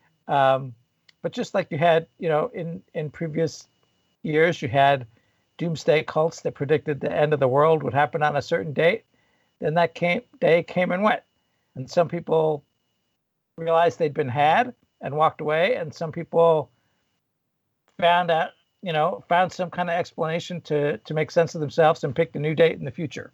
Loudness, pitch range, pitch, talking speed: -23 LUFS, 150-170 Hz, 160 Hz, 185 wpm